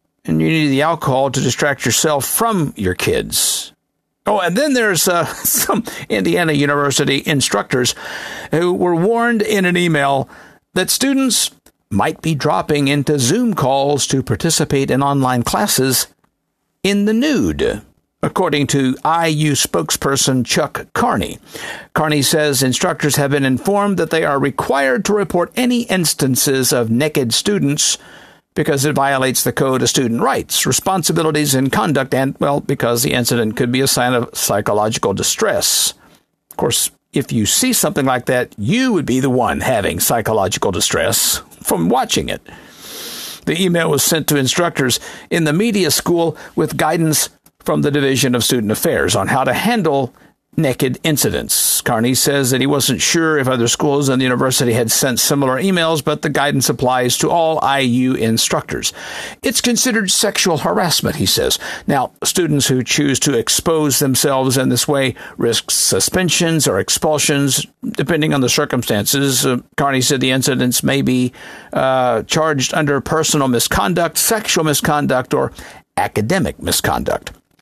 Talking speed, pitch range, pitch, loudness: 150 wpm, 130-165 Hz, 145 Hz, -15 LUFS